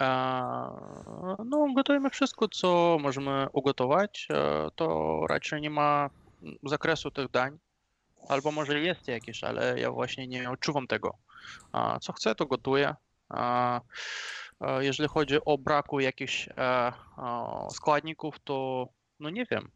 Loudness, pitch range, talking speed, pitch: -30 LUFS, 125-155 Hz, 110 wpm, 140 Hz